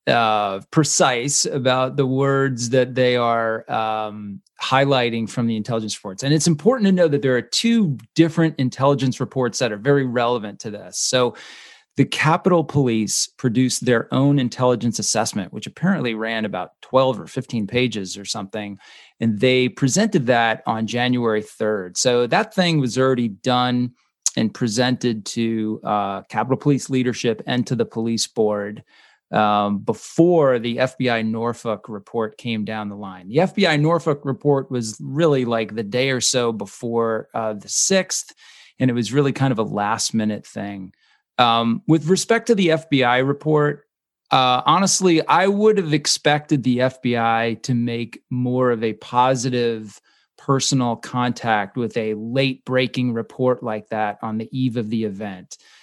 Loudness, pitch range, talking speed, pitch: -20 LUFS, 110-135 Hz, 160 wpm, 125 Hz